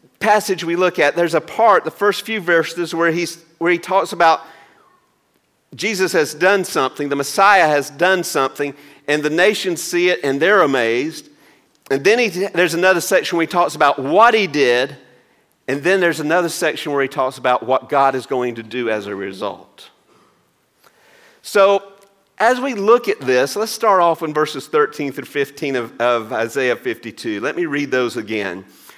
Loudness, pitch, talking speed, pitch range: -17 LUFS, 170 Hz, 180 wpm, 140-195 Hz